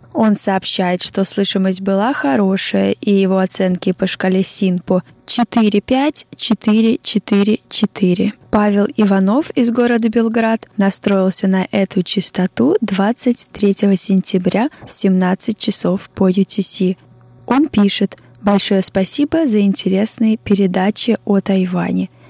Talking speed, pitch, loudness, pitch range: 100 wpm, 200 Hz, -15 LUFS, 190-220 Hz